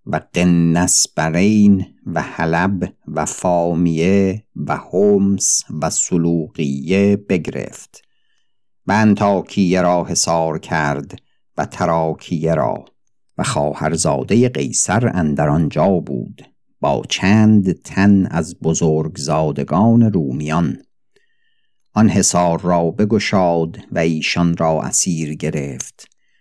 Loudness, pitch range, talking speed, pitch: -16 LUFS, 80-100 Hz, 95 wpm, 85 Hz